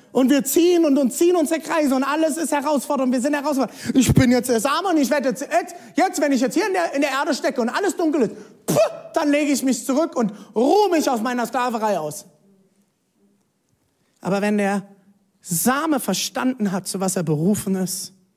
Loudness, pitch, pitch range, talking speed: -20 LUFS, 260 Hz, 200-300 Hz, 210 wpm